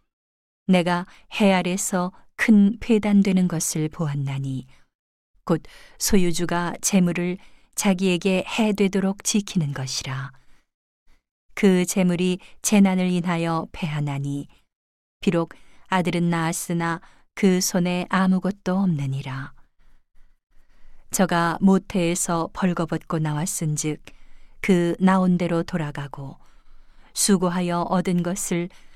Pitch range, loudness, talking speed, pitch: 165-190 Hz, -22 LUFS, 215 characters per minute, 180 Hz